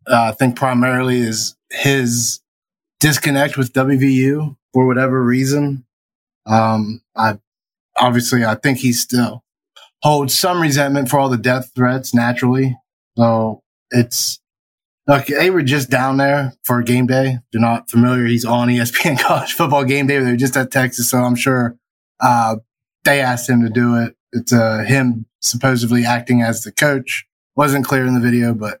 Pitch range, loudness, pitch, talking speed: 120-135 Hz, -16 LUFS, 125 Hz, 160 wpm